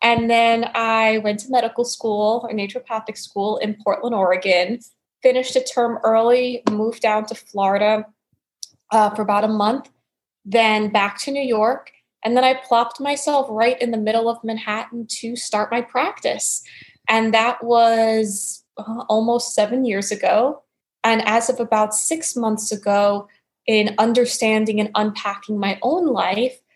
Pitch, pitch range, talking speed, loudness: 225 Hz, 215-240 Hz, 155 wpm, -19 LUFS